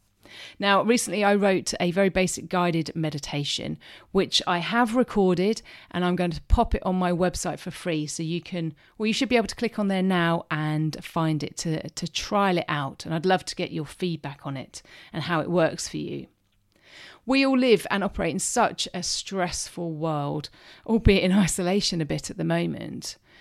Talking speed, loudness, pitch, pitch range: 200 wpm, -25 LUFS, 180 Hz, 160-195 Hz